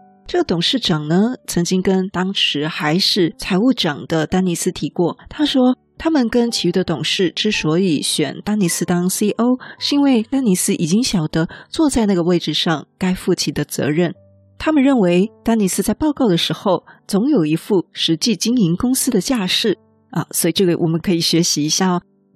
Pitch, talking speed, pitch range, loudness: 185 Hz, 285 characters per minute, 170-220 Hz, -17 LUFS